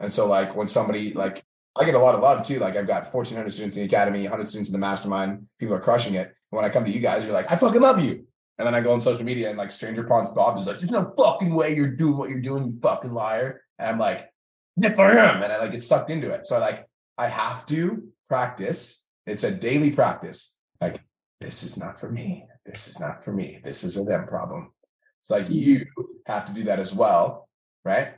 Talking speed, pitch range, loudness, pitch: 250 wpm, 100-145 Hz, -23 LUFS, 120 Hz